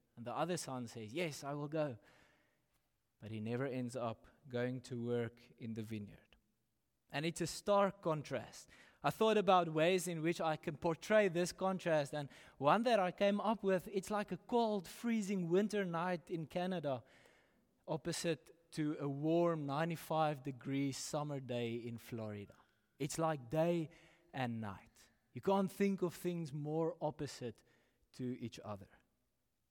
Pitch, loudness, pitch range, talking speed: 155 Hz, -39 LUFS, 120-175 Hz, 155 wpm